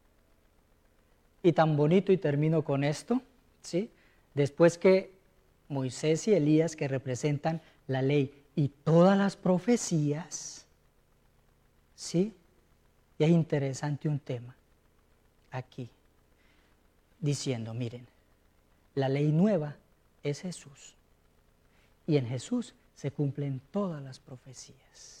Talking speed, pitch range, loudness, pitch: 100 wpm, 130-170 Hz, -29 LUFS, 145 Hz